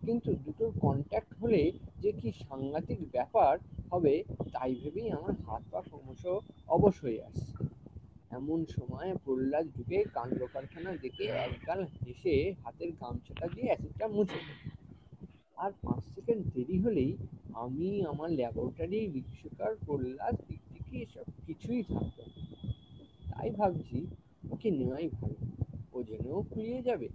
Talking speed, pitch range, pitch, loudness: 120 wpm, 120-185 Hz, 140 Hz, -35 LUFS